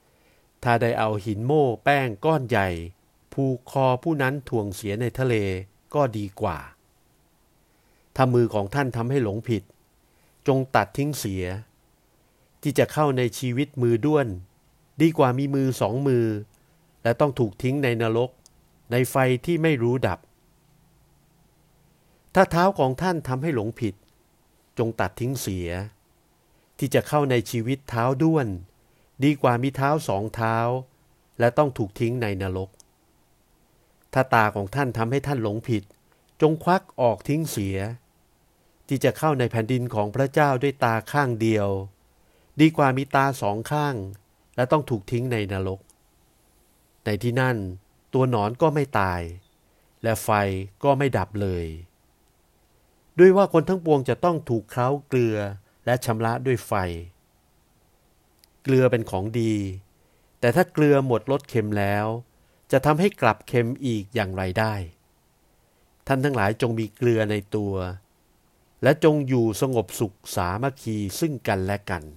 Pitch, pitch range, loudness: 120 Hz, 105-140 Hz, -24 LUFS